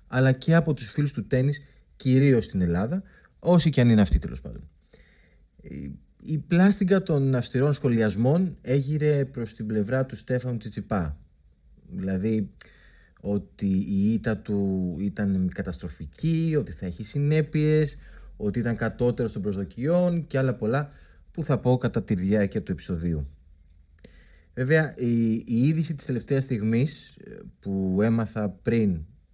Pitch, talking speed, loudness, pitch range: 115 Hz, 135 wpm, -25 LUFS, 100-140 Hz